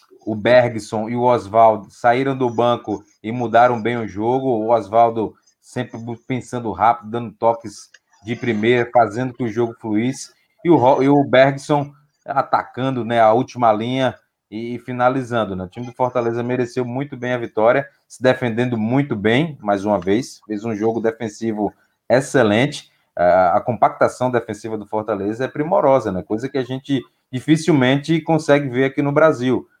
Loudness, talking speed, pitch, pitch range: -18 LUFS, 155 wpm, 120 Hz, 110-130 Hz